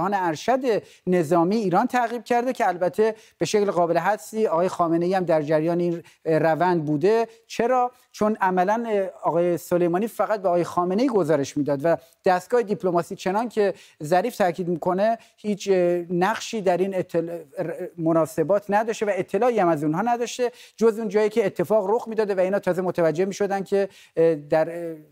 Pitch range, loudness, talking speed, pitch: 170-220 Hz, -23 LUFS, 160 wpm, 185 Hz